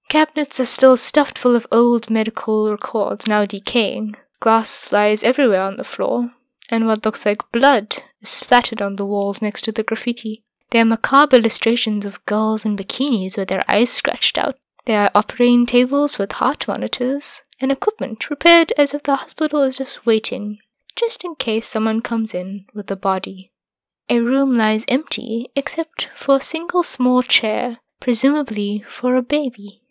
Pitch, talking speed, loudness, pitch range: 235 Hz, 170 wpm, -18 LUFS, 215-270 Hz